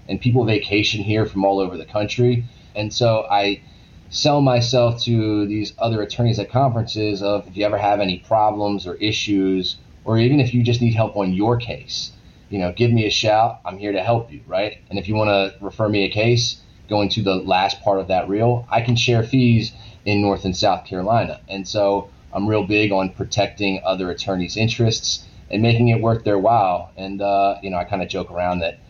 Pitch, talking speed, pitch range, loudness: 105 Hz, 215 wpm, 95-115 Hz, -19 LUFS